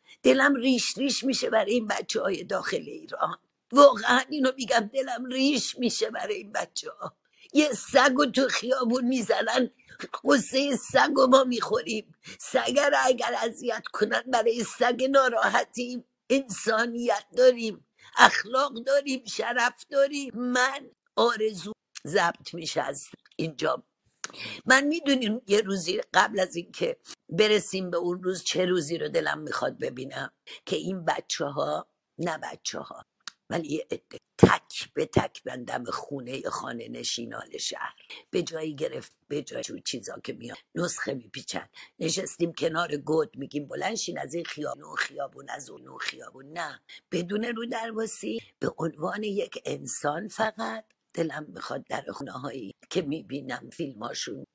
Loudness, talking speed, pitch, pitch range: -27 LUFS, 135 wpm, 240 Hz, 190-265 Hz